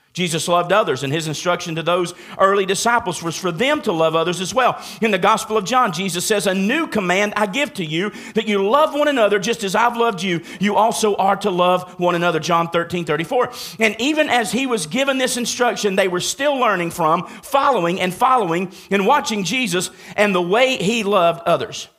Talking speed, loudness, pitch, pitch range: 210 wpm, -18 LUFS, 200 Hz, 180-235 Hz